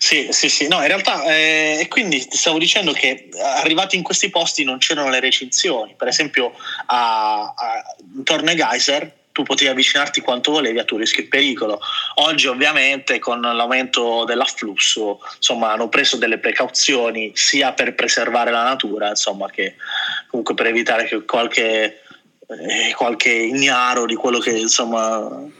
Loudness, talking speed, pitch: -16 LUFS, 150 wpm, 140 Hz